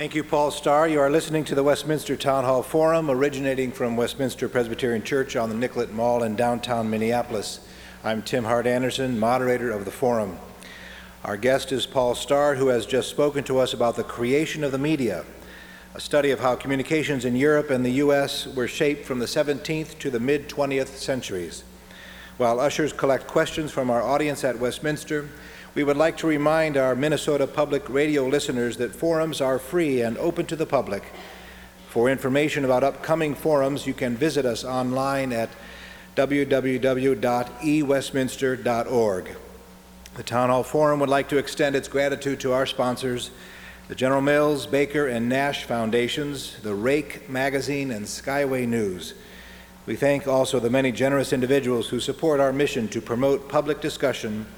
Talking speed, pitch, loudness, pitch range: 165 wpm, 135 Hz, -24 LUFS, 120-145 Hz